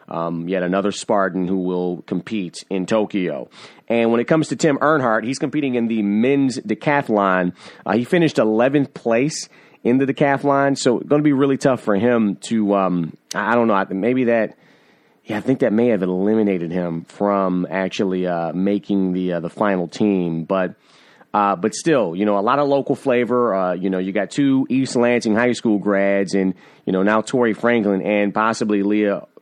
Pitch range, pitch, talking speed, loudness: 95-125 Hz, 105 Hz, 190 wpm, -19 LUFS